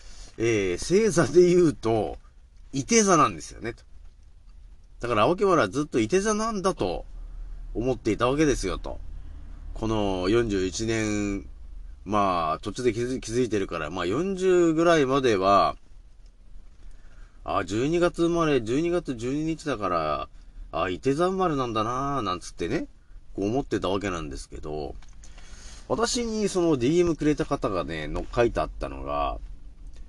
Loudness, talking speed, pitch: -25 LUFS, 265 characters per minute, 110 Hz